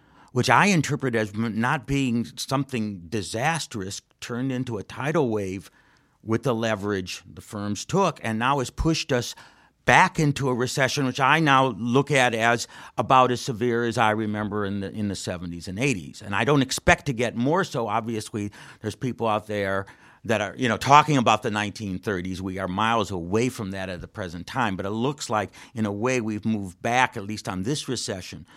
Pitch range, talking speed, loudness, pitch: 105-130 Hz, 195 wpm, -24 LUFS, 115 Hz